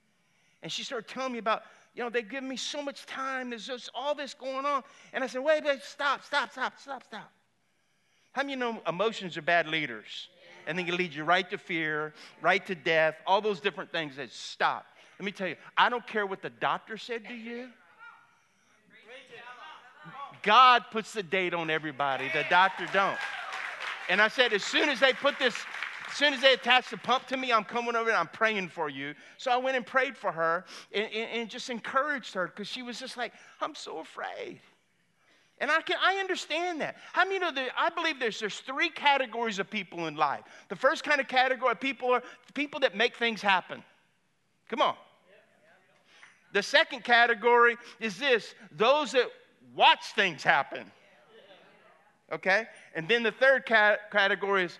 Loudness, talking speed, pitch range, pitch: -28 LUFS, 195 wpm, 195-270 Hz, 235 Hz